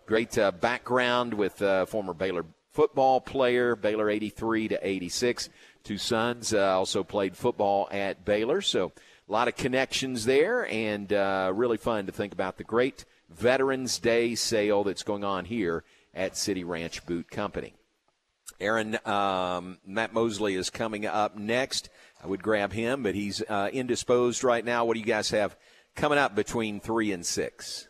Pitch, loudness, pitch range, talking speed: 105 Hz, -28 LUFS, 100-120 Hz, 170 wpm